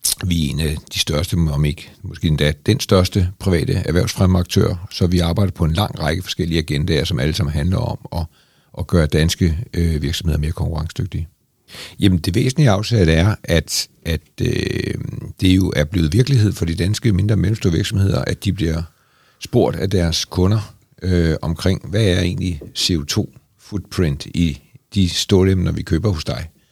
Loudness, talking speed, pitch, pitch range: -18 LUFS, 175 wpm, 90 Hz, 80-105 Hz